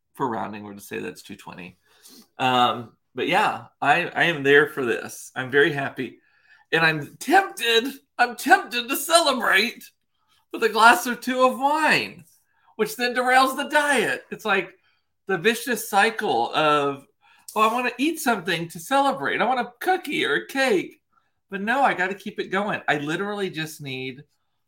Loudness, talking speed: -22 LUFS, 180 wpm